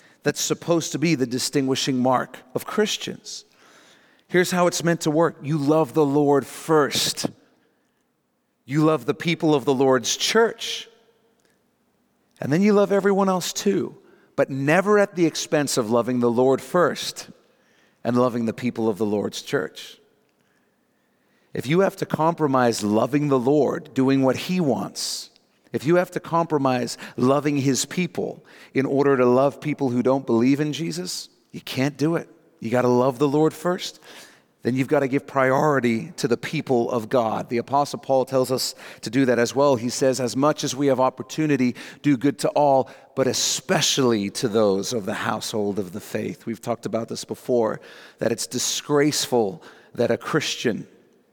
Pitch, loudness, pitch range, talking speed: 140 Hz, -22 LUFS, 125-160 Hz, 175 wpm